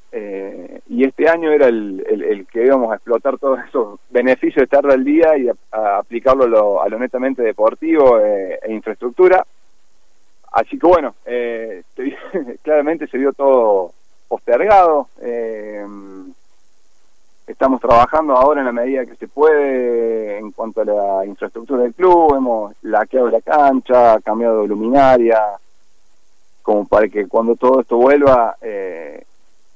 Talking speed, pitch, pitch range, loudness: 150 wpm, 125 Hz, 110-150 Hz, -15 LUFS